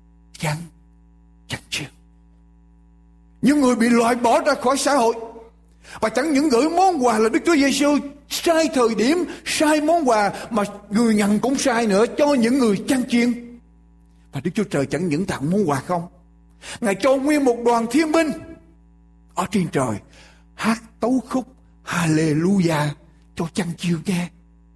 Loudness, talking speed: -20 LUFS, 160 wpm